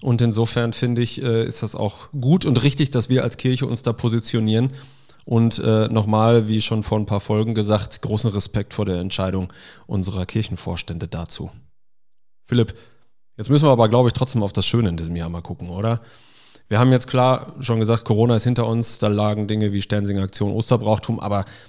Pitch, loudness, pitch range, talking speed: 115 Hz, -20 LUFS, 105-120 Hz, 190 wpm